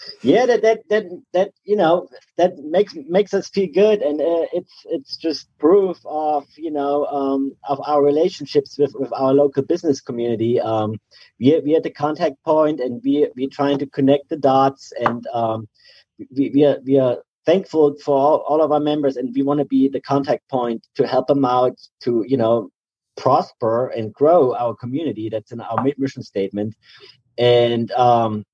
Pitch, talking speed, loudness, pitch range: 140 Hz, 190 wpm, -19 LUFS, 125-155 Hz